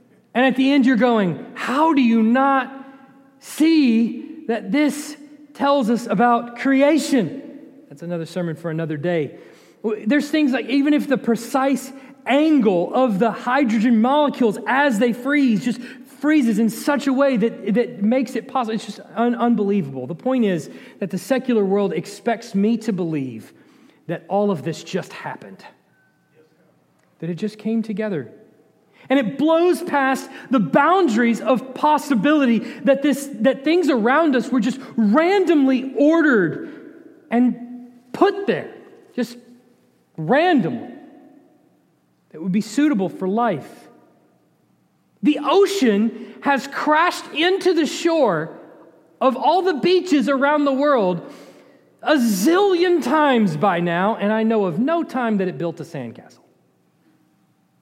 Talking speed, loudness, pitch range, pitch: 140 wpm, -19 LUFS, 215-290 Hz, 255 Hz